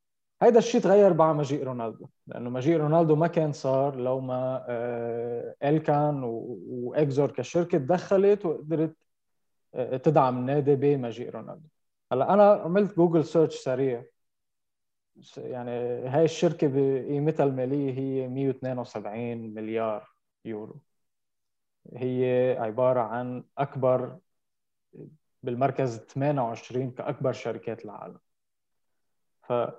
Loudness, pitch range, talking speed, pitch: -26 LUFS, 125-155 Hz, 95 wpm, 135 Hz